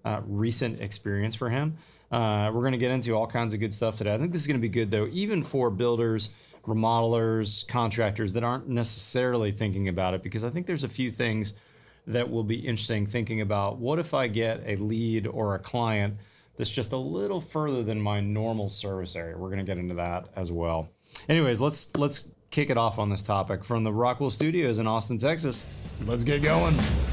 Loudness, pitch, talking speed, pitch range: -28 LUFS, 115 Hz, 205 wpm, 105-125 Hz